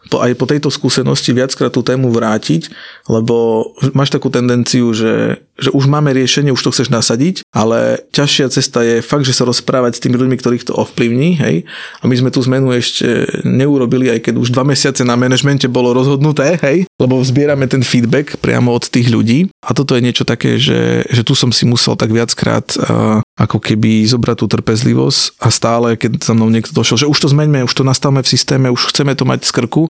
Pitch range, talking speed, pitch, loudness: 120-140 Hz, 200 wpm, 125 Hz, -12 LUFS